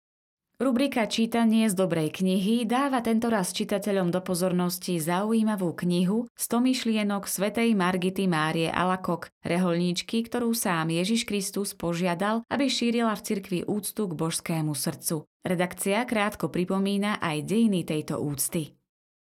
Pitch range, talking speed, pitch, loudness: 175-225 Hz, 120 wpm, 195 Hz, -26 LUFS